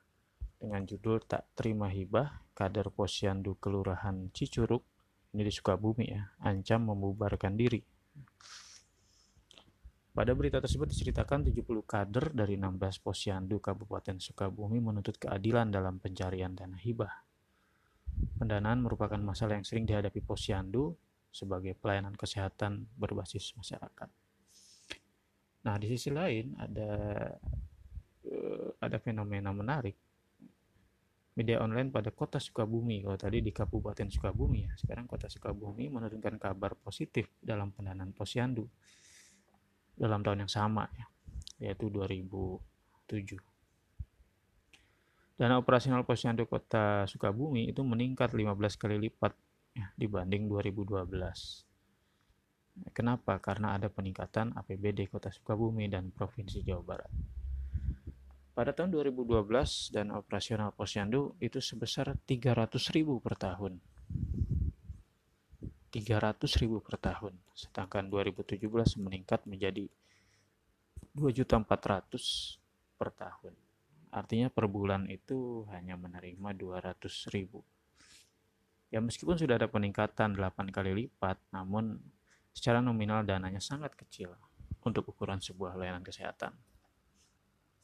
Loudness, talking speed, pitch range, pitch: -36 LUFS, 105 wpm, 95-115 Hz, 105 Hz